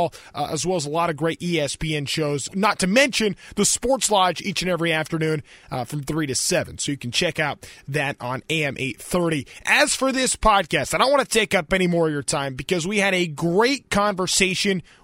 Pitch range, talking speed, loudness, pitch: 150-195 Hz, 220 wpm, -21 LUFS, 170 Hz